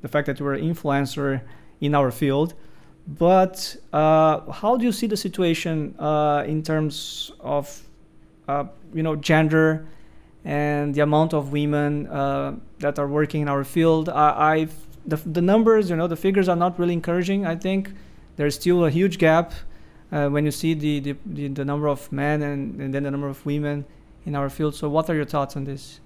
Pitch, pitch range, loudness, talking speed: 150 Hz, 145-165 Hz, -22 LUFS, 195 wpm